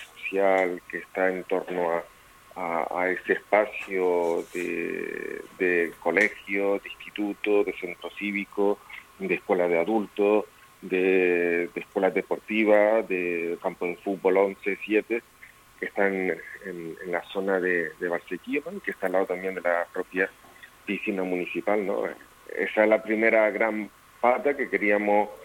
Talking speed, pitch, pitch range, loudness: 140 wpm, 95 Hz, 90-105 Hz, -26 LUFS